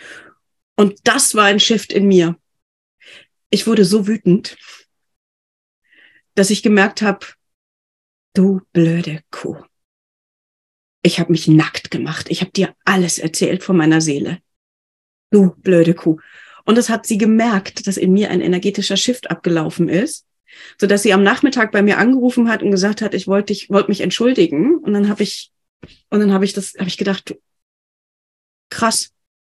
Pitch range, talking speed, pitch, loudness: 175-210 Hz, 160 wpm, 195 Hz, -15 LUFS